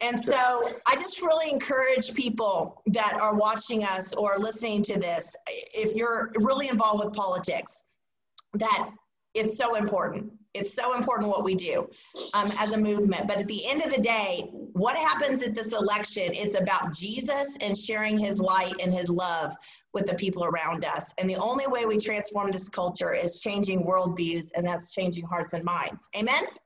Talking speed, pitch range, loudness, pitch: 180 wpm, 185-235 Hz, -27 LUFS, 210 Hz